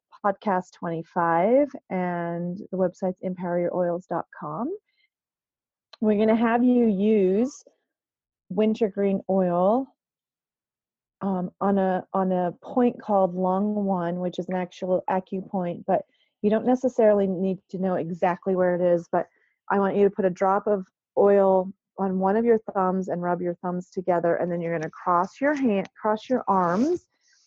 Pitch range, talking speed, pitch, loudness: 180-215 Hz, 155 wpm, 190 Hz, -24 LUFS